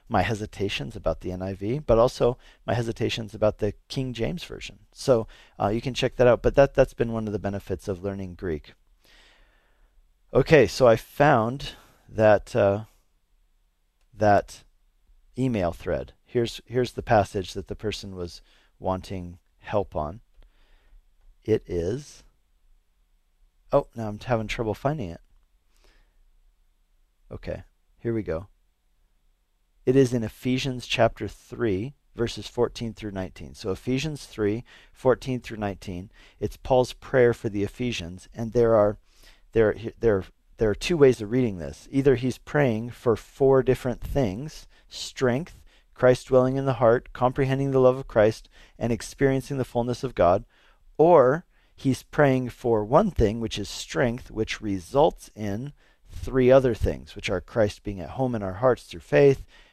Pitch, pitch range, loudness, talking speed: 110 Hz, 95-125 Hz, -25 LUFS, 150 wpm